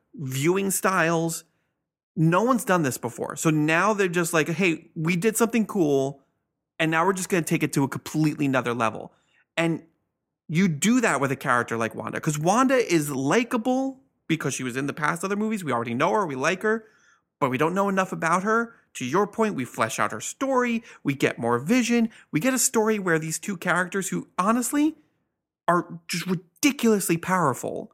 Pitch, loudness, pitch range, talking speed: 170 Hz, -24 LUFS, 150-215 Hz, 195 wpm